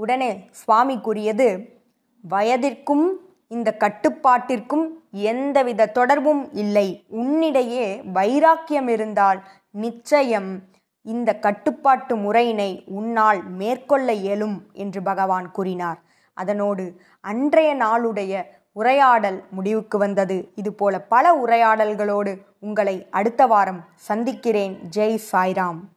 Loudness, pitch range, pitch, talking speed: -20 LUFS, 195-250 Hz, 215 Hz, 85 wpm